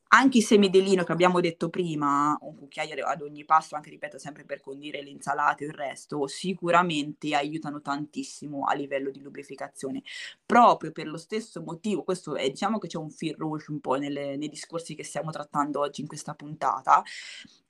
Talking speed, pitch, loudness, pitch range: 190 wpm, 150 Hz, -27 LUFS, 140-170 Hz